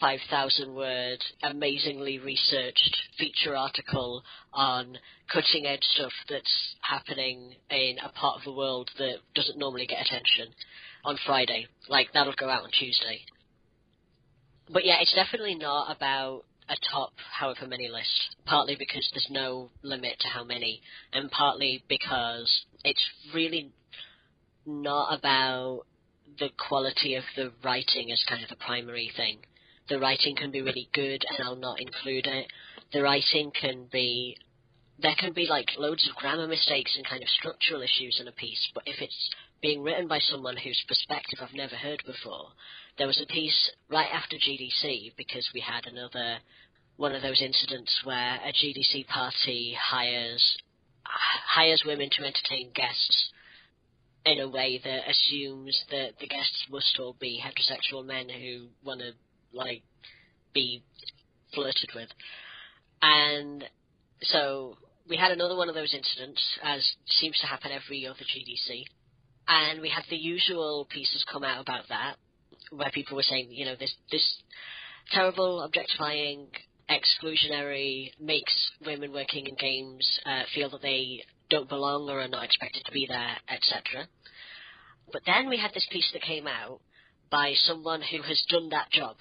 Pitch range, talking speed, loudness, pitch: 125-145 Hz, 155 wpm, -27 LUFS, 135 Hz